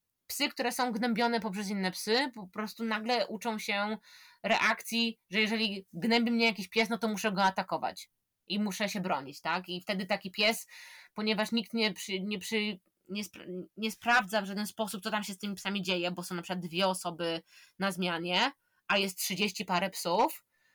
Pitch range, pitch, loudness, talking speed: 190-225 Hz, 210 Hz, -32 LUFS, 190 wpm